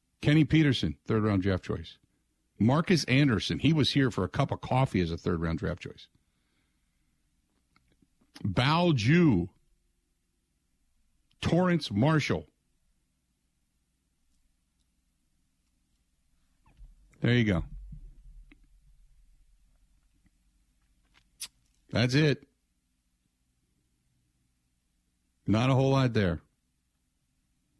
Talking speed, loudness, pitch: 80 wpm, -27 LUFS, 80 Hz